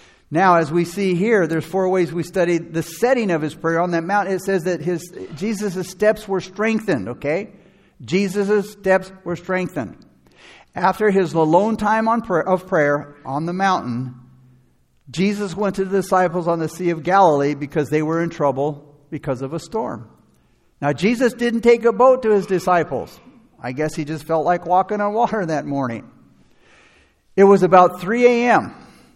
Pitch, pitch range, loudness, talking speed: 180 Hz, 160-200 Hz, -19 LUFS, 175 wpm